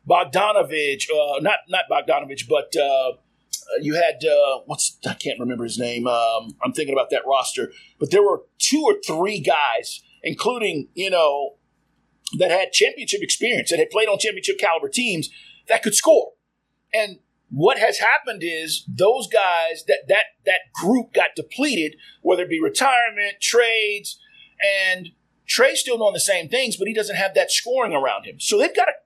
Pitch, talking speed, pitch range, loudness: 205 Hz, 170 wpm, 165-275 Hz, -20 LUFS